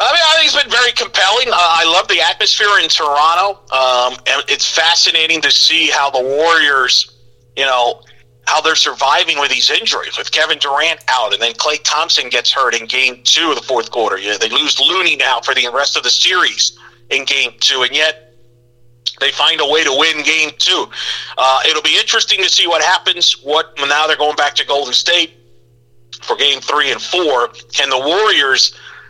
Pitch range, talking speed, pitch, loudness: 120-165 Hz, 200 wpm, 140 Hz, -12 LUFS